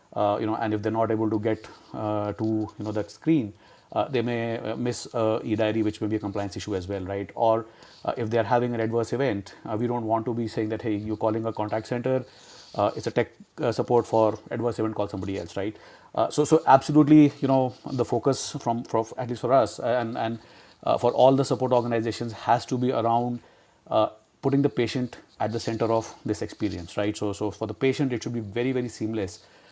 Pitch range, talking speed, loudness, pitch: 110-125 Hz, 230 wpm, -26 LUFS, 115 Hz